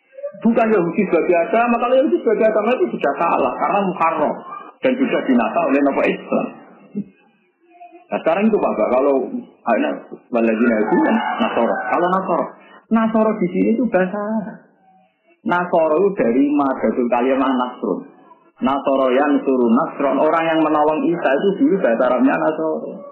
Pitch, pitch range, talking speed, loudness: 190 Hz, 150-230 Hz, 140 wpm, -18 LUFS